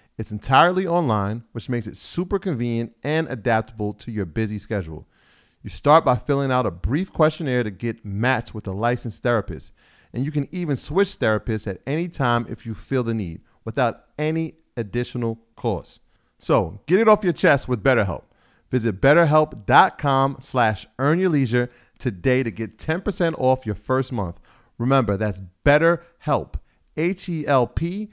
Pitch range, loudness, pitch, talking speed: 110-150 Hz, -22 LUFS, 125 Hz, 155 wpm